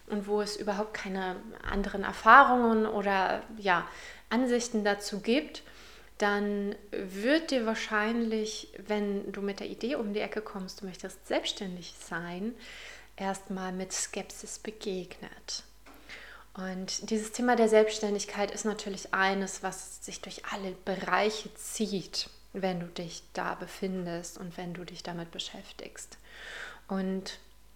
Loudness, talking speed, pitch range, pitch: -31 LUFS, 130 wpm, 190-215 Hz, 205 Hz